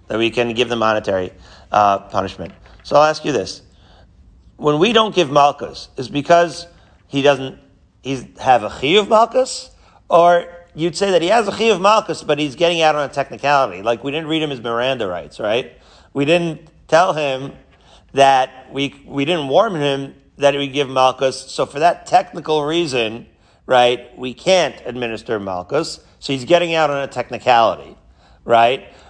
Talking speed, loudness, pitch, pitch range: 180 wpm, -17 LUFS, 140 Hz, 120-170 Hz